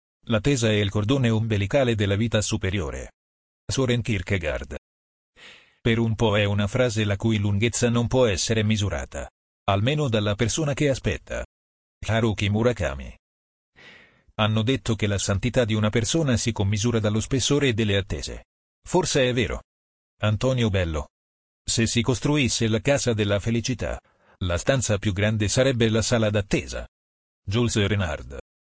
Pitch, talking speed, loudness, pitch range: 105 Hz, 140 wpm, -23 LUFS, 85-120 Hz